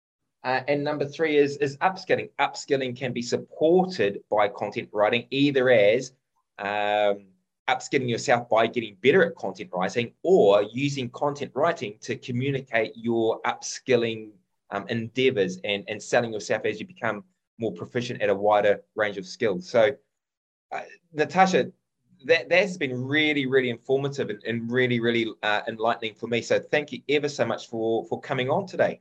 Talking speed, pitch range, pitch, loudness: 160 wpm, 105-140 Hz, 120 Hz, -25 LUFS